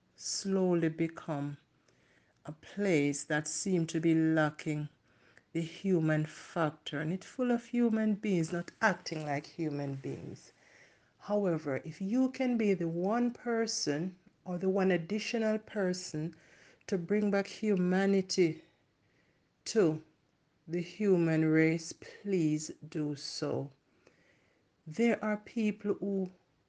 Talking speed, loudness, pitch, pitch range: 115 wpm, -33 LUFS, 175 Hz, 155-200 Hz